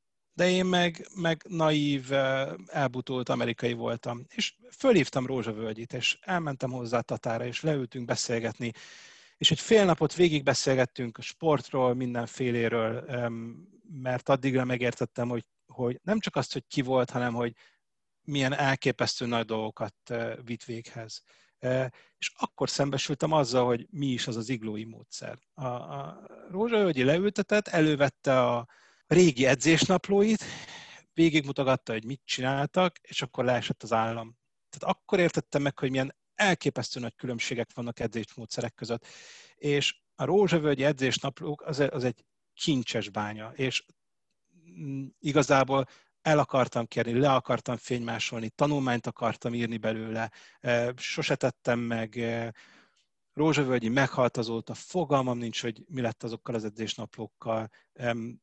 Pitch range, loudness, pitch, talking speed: 120-150 Hz, -29 LUFS, 130 Hz, 125 wpm